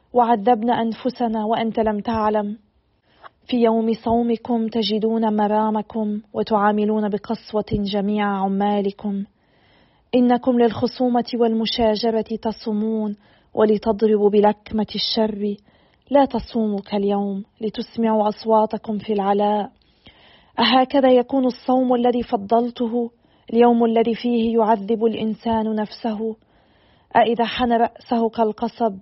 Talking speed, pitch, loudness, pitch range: 90 wpm, 225 Hz, -20 LUFS, 215-235 Hz